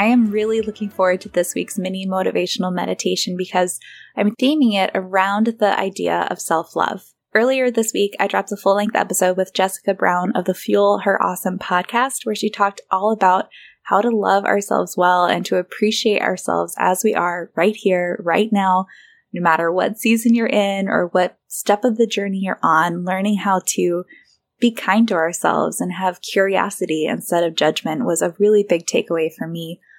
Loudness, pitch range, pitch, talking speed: -18 LUFS, 180-210 Hz, 195 Hz, 190 wpm